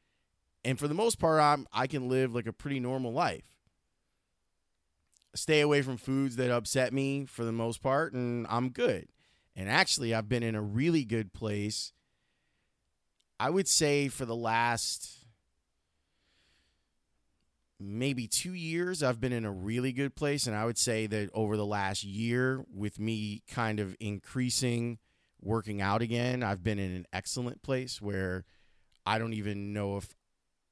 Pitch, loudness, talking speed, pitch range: 115 Hz, -32 LUFS, 160 wpm, 95-130 Hz